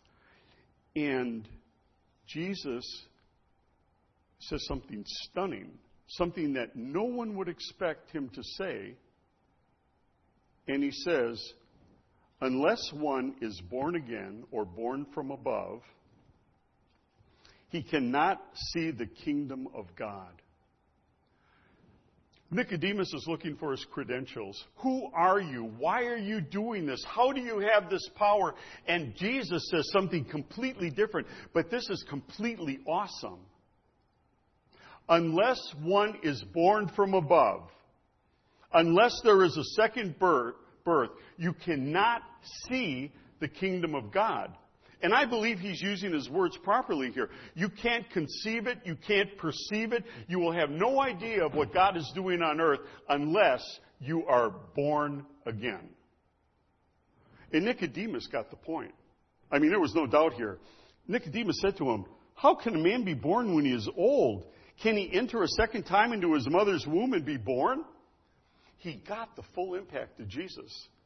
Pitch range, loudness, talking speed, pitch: 140-215 Hz, -30 LUFS, 140 wpm, 175 Hz